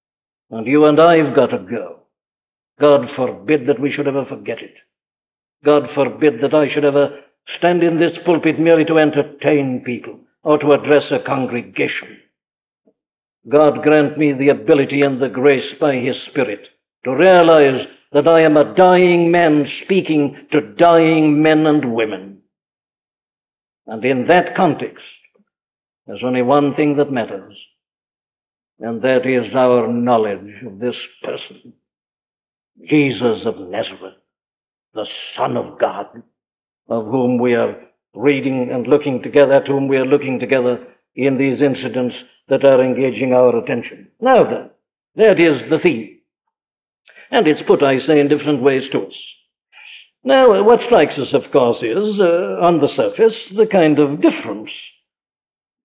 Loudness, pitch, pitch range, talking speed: -15 LUFS, 145 Hz, 130-160 Hz, 150 wpm